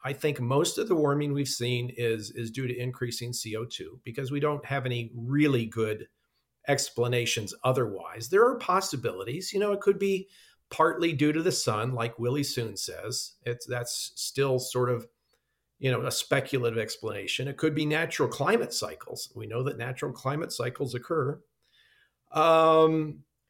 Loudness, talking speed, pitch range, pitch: -28 LUFS, 165 wpm, 120-150 Hz, 130 Hz